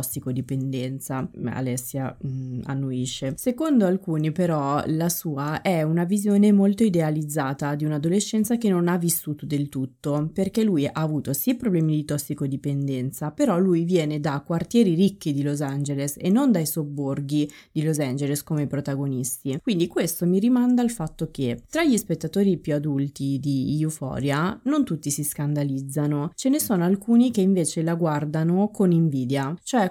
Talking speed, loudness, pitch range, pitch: 155 wpm, -24 LUFS, 140-185 Hz, 155 Hz